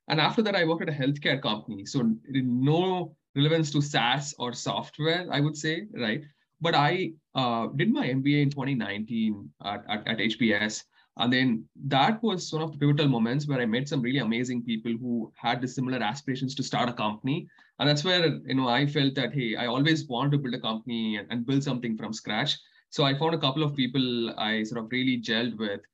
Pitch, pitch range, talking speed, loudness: 135 Hz, 120-150 Hz, 210 wpm, -27 LUFS